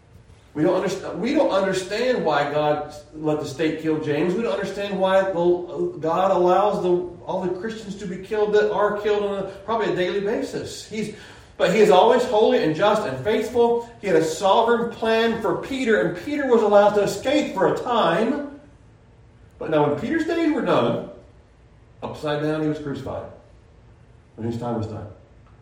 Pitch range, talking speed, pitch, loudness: 150-215 Hz, 185 wpm, 190 Hz, -21 LUFS